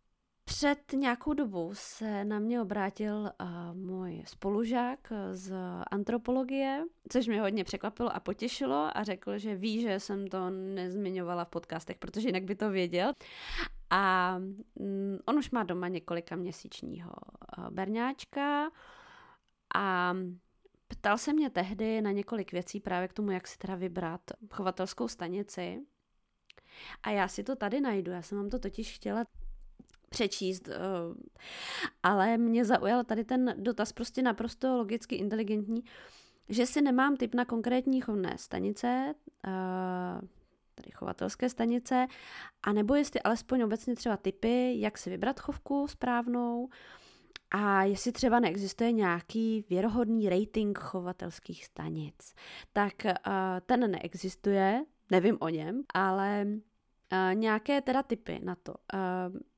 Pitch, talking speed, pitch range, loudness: 210 Hz, 125 wpm, 185-245 Hz, -33 LUFS